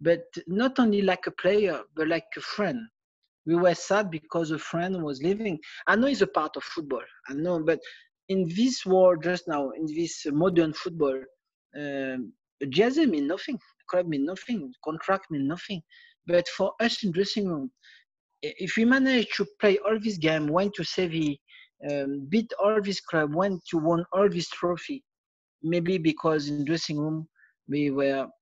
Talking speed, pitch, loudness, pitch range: 175 wpm, 180 Hz, -27 LUFS, 155-205 Hz